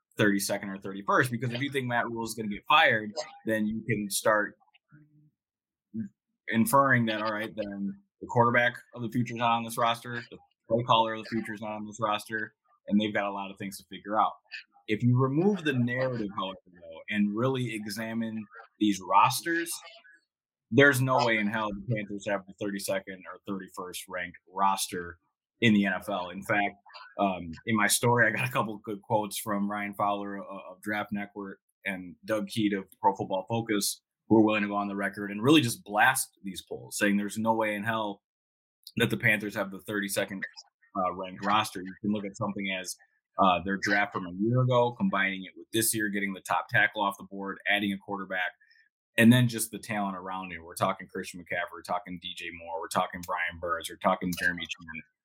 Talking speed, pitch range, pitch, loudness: 205 wpm, 100-115 Hz, 105 Hz, -28 LUFS